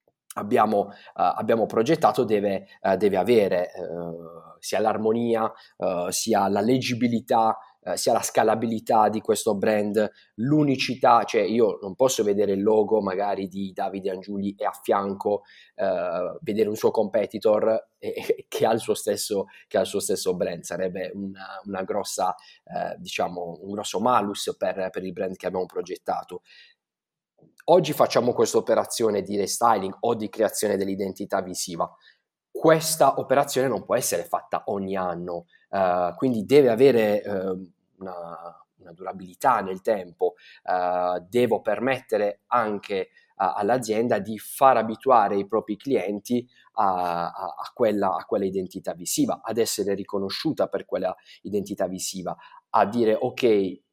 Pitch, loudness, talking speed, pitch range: 110 Hz, -24 LUFS, 140 wpm, 95-130 Hz